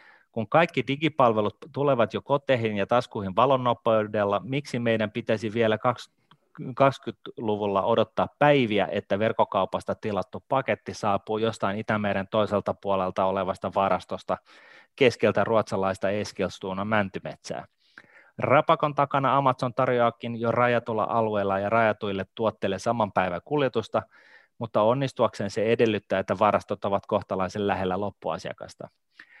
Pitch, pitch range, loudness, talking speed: 110 Hz, 100-125 Hz, -25 LUFS, 110 wpm